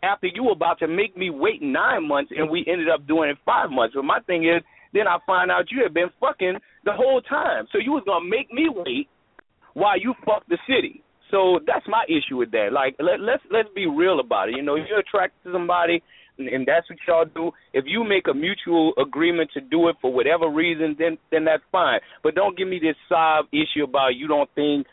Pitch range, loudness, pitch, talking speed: 155-230 Hz, -22 LUFS, 170 Hz, 240 wpm